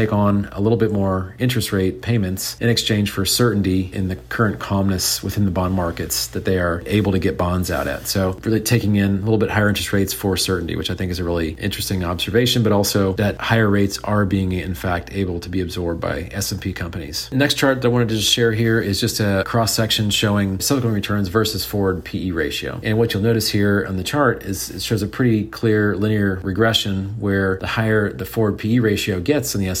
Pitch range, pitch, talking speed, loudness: 95-110 Hz, 100 Hz, 230 wpm, -19 LUFS